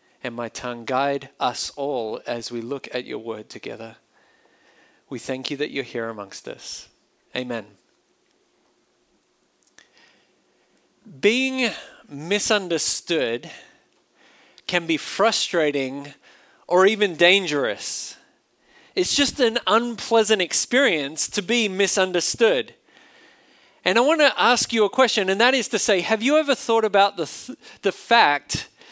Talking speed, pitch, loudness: 125 wpm, 190 Hz, -21 LUFS